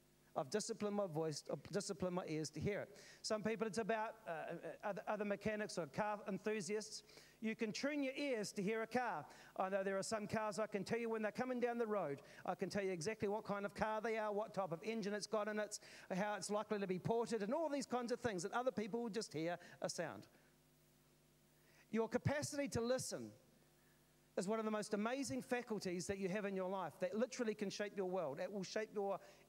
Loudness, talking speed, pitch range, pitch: -43 LUFS, 230 wpm, 195-225 Hz, 210 Hz